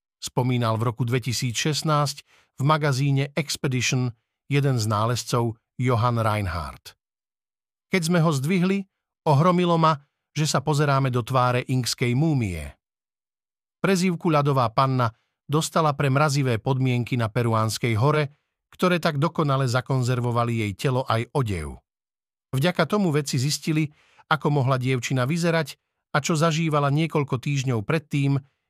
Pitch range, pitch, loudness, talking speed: 125-155 Hz, 135 Hz, -23 LUFS, 120 wpm